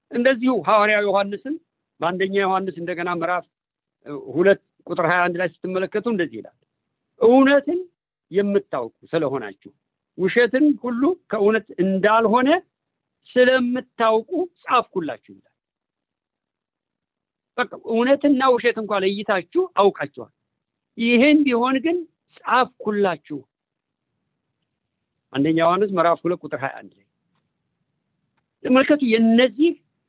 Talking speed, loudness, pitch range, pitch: 90 wpm, -20 LUFS, 185-260 Hz, 220 Hz